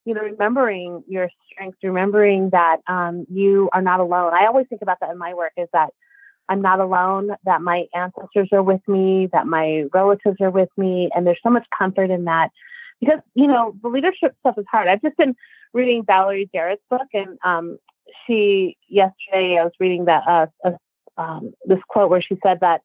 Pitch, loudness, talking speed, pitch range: 190 Hz, -19 LUFS, 200 wpm, 180-220 Hz